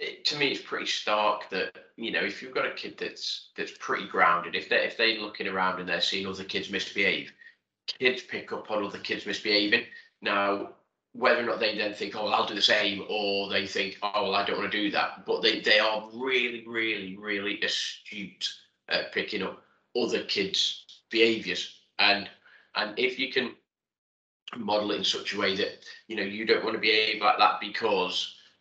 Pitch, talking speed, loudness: 110 Hz, 205 wpm, -27 LUFS